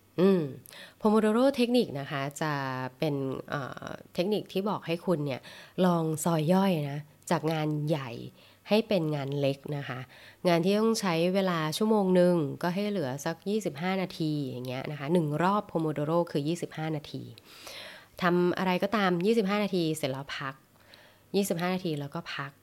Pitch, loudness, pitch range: 170 Hz, -29 LUFS, 145-190 Hz